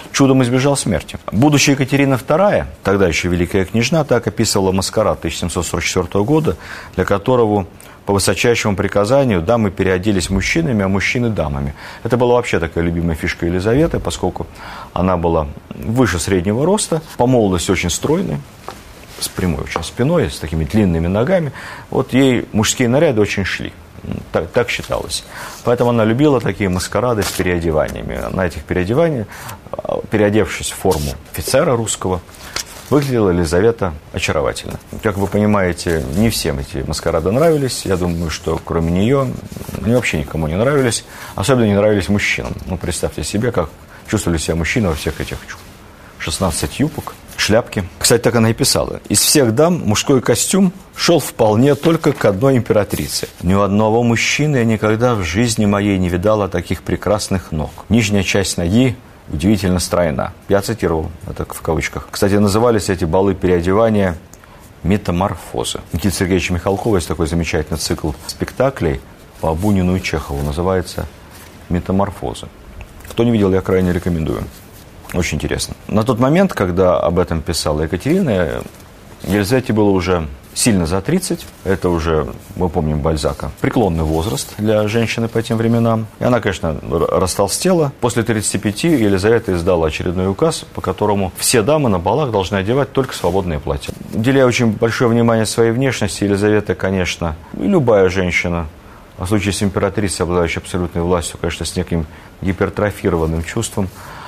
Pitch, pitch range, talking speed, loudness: 100 Hz, 90-115 Hz, 145 wpm, -16 LUFS